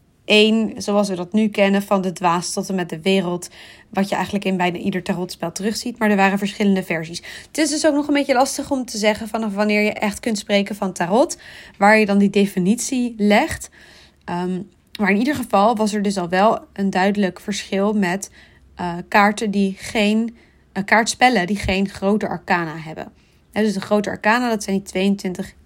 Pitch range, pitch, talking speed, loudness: 190-215 Hz, 200 Hz, 200 wpm, -19 LUFS